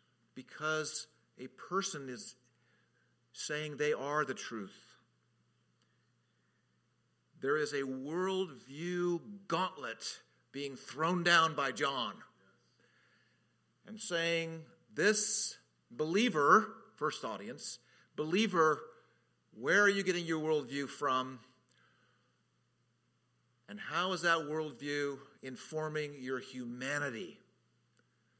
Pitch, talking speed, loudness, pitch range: 155 Hz, 85 wpm, -34 LUFS, 135-175 Hz